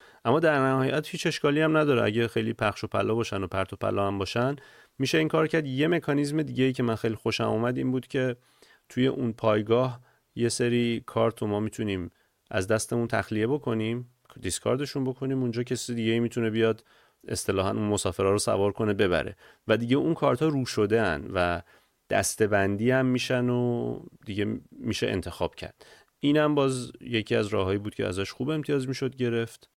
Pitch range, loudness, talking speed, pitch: 110-130 Hz, -27 LUFS, 185 wpm, 120 Hz